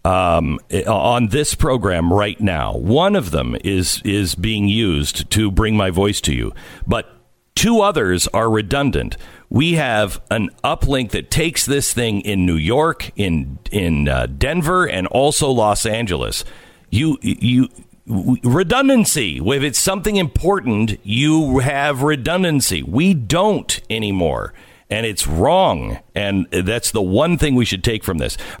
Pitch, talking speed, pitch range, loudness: 110 Hz, 145 wpm, 95-140 Hz, -17 LUFS